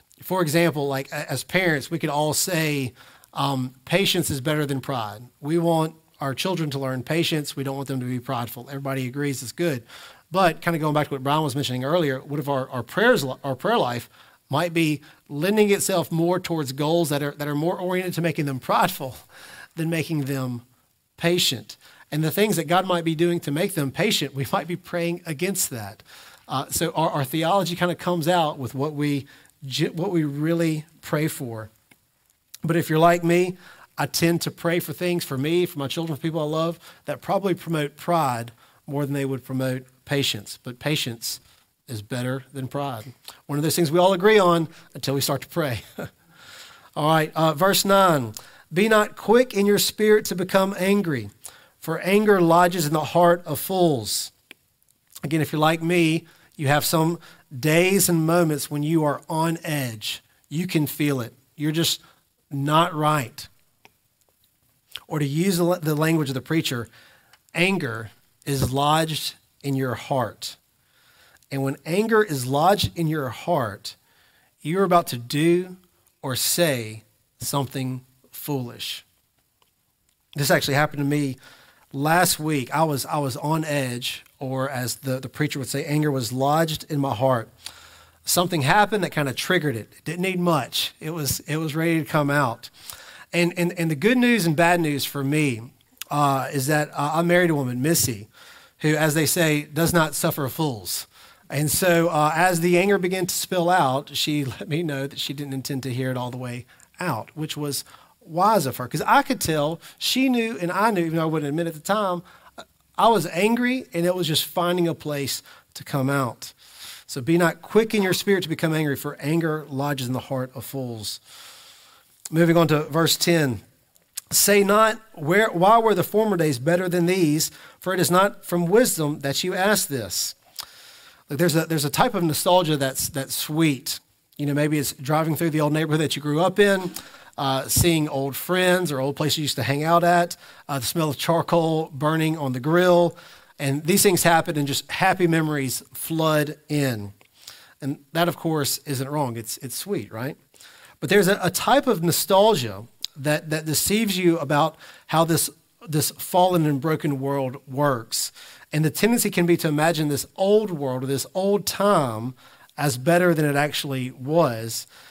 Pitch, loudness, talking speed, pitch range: 155 Hz, -22 LUFS, 190 wpm, 135-175 Hz